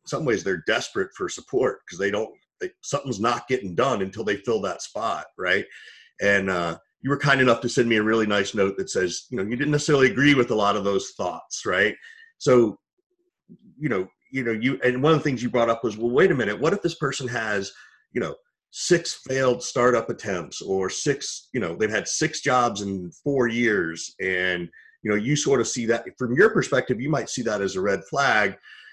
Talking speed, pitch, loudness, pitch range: 225 wpm, 120 Hz, -23 LUFS, 105-145 Hz